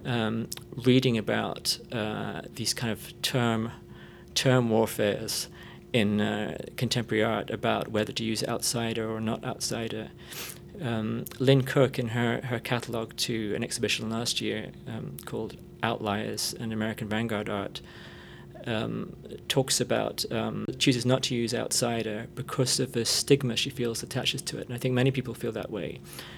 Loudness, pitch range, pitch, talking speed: -29 LUFS, 110-125 Hz, 115 Hz, 150 wpm